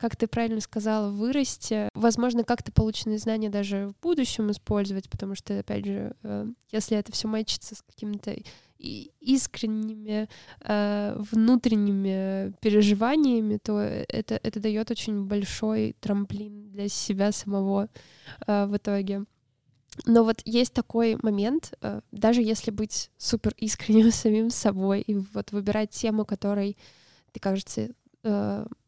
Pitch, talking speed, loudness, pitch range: 215 Hz, 120 wpm, -27 LUFS, 205-225 Hz